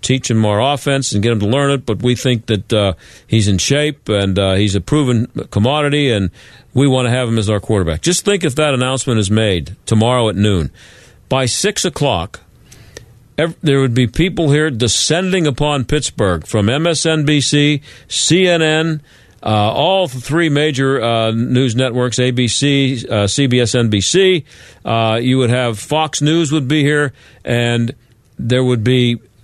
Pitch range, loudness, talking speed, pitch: 115-150 Hz, -15 LUFS, 165 wpm, 125 Hz